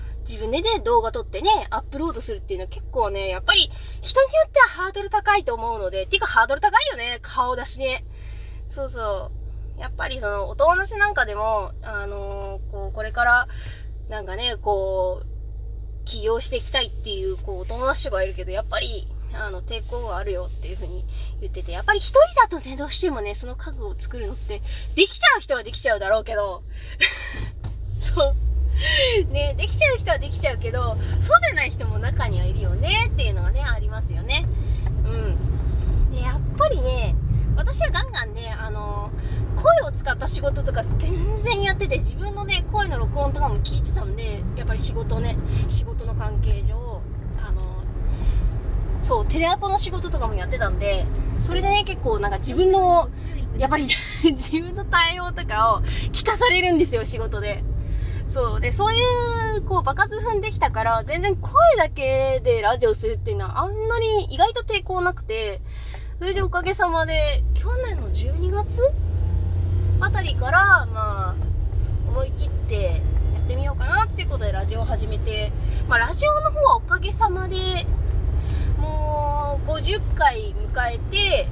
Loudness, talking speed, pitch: -22 LUFS, 340 characters per minute, 115 Hz